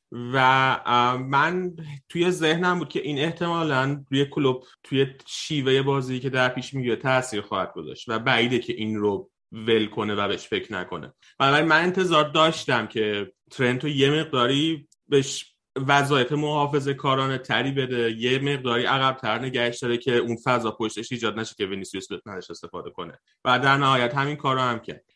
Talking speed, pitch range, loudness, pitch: 165 wpm, 120-145 Hz, -23 LUFS, 130 Hz